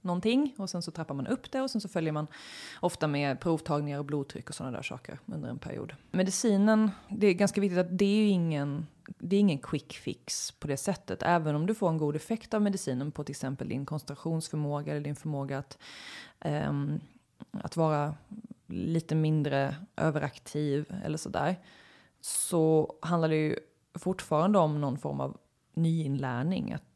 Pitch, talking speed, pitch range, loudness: 160 Hz, 170 wpm, 145-195 Hz, -31 LUFS